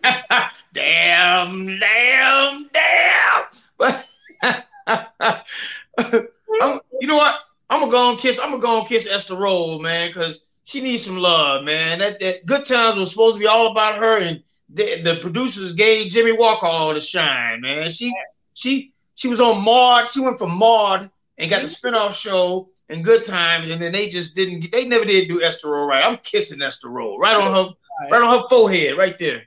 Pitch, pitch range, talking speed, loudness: 220 Hz, 180-250 Hz, 185 wpm, -17 LUFS